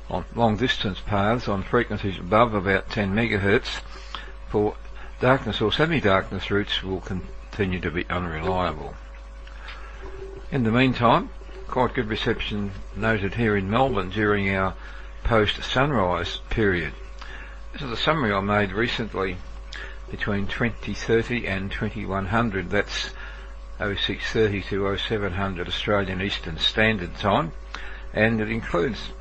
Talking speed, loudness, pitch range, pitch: 115 wpm, -24 LUFS, 95-115 Hz, 100 Hz